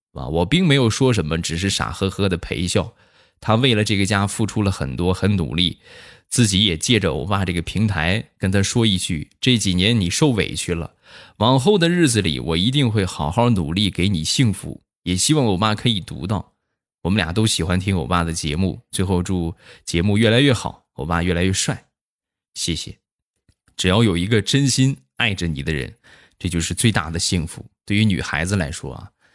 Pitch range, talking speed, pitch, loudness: 85-110 Hz, 280 characters per minute, 95 Hz, -19 LUFS